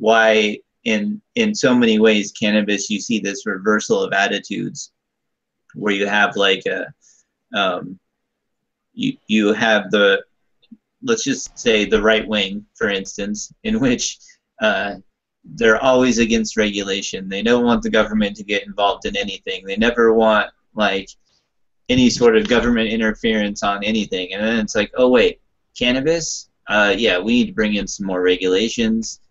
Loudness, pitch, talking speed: -18 LUFS, 110 Hz, 155 wpm